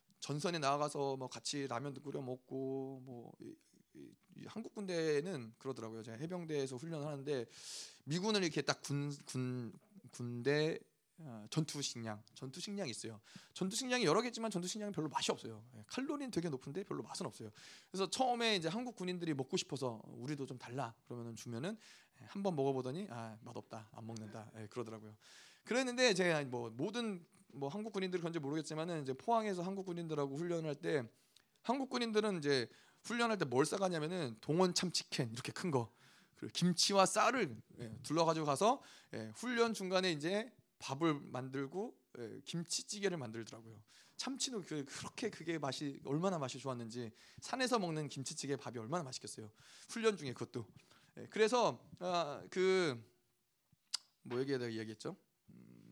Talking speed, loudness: 350 characters per minute, -39 LUFS